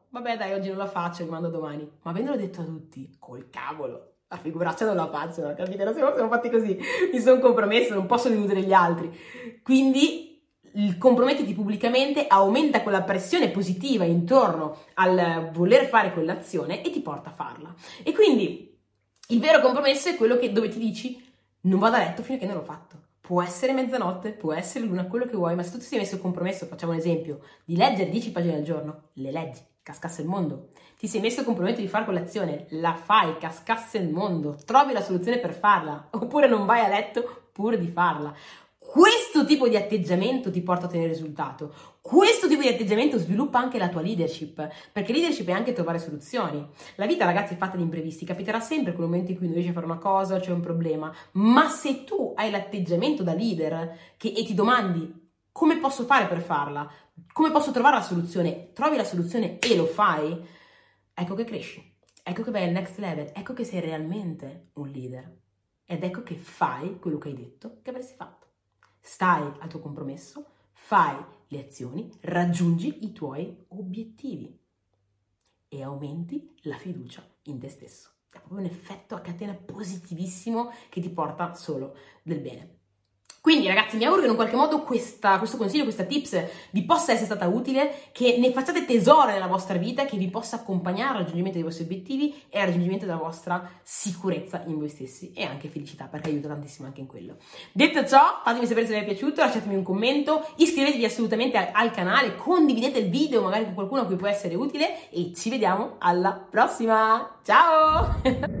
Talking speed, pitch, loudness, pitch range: 190 wpm, 195 Hz, -24 LUFS, 170-240 Hz